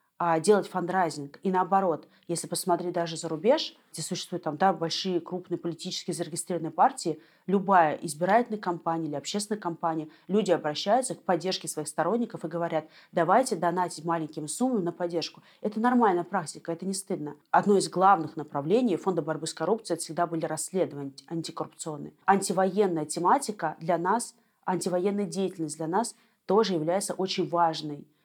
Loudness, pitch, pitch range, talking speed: -28 LUFS, 175 Hz, 160-195 Hz, 150 wpm